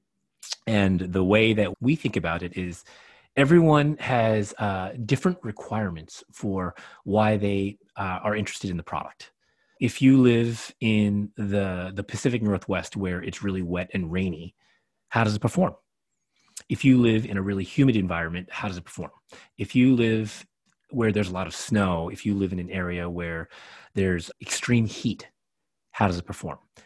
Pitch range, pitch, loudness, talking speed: 90-115 Hz, 100 Hz, -25 LUFS, 170 wpm